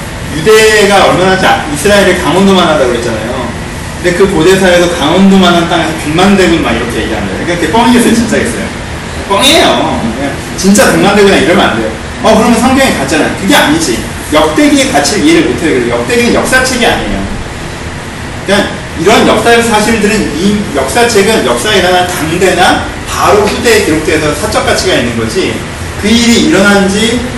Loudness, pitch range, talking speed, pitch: -7 LUFS, 175-225 Hz, 390 characters per minute, 195 Hz